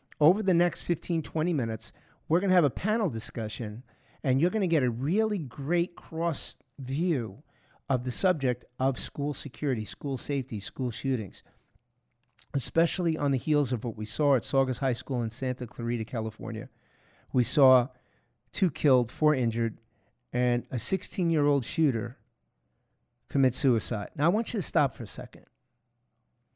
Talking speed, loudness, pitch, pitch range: 165 wpm, -28 LUFS, 130 Hz, 120-155 Hz